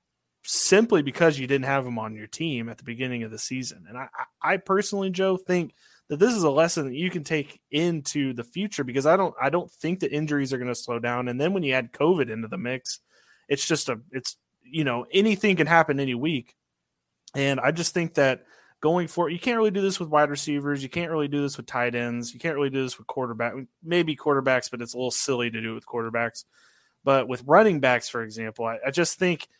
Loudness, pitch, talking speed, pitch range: -24 LUFS, 140 Hz, 240 wpm, 120-165 Hz